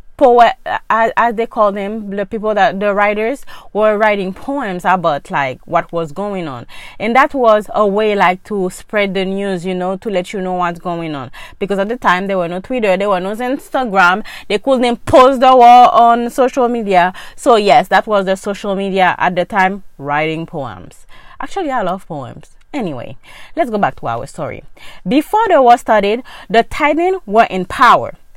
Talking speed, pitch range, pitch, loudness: 190 wpm, 180-240 Hz, 205 Hz, -13 LUFS